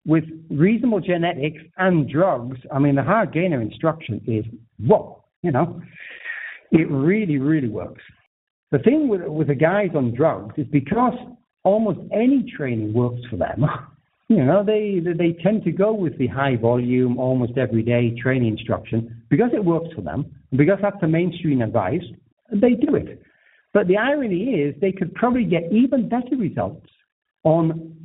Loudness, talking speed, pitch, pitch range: -21 LUFS, 165 wpm, 160 Hz, 130-200 Hz